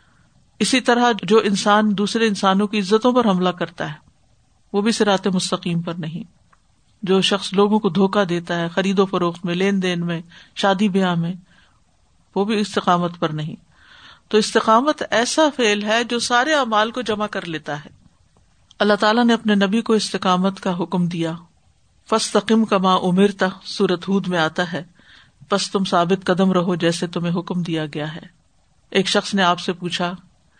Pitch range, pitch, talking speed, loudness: 175-210 Hz, 195 Hz, 175 wpm, -19 LUFS